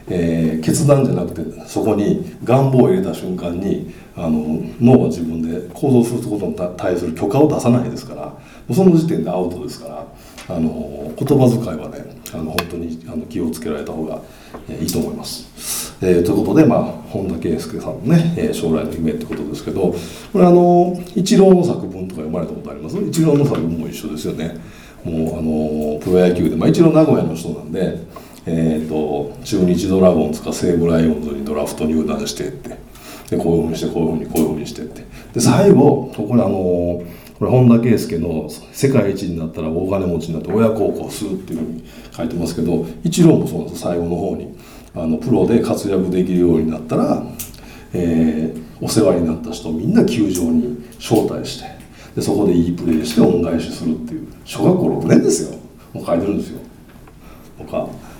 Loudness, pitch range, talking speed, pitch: -17 LUFS, 80-120 Hz, 385 characters per minute, 85 Hz